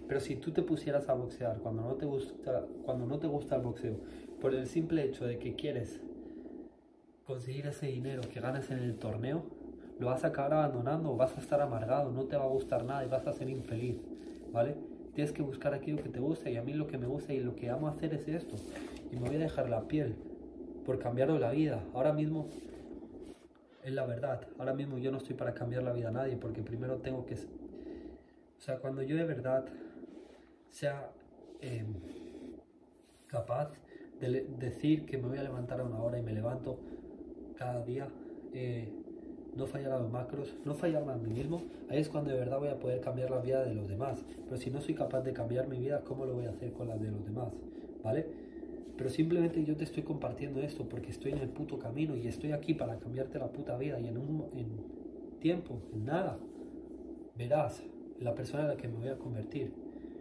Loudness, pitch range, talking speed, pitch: -37 LUFS, 125-155 Hz, 215 wpm, 135 Hz